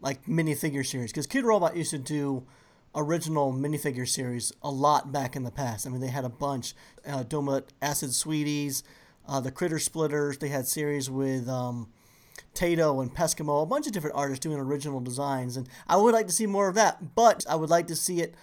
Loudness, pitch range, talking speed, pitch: -28 LUFS, 130-160 Hz, 210 wpm, 145 Hz